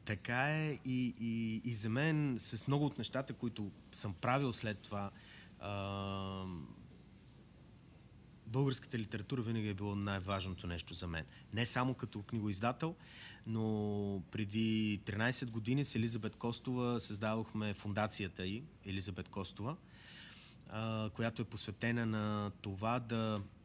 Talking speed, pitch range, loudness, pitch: 125 wpm, 100-120 Hz, -38 LUFS, 110 Hz